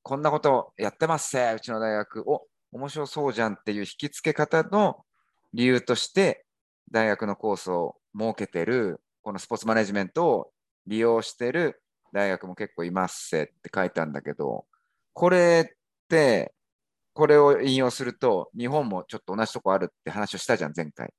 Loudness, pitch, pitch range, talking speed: -25 LUFS, 120 Hz, 105-150 Hz, 345 characters per minute